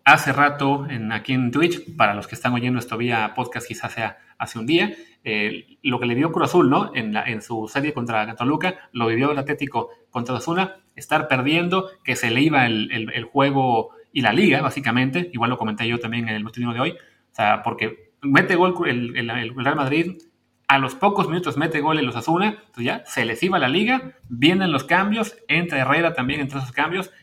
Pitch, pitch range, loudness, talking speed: 130 Hz, 120-155 Hz, -21 LUFS, 220 wpm